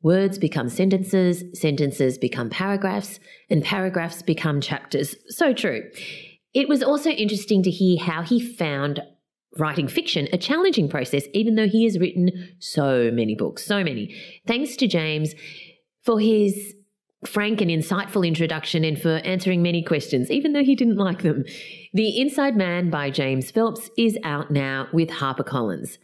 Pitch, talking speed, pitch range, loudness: 180 Hz, 155 wpm, 155-210 Hz, -22 LUFS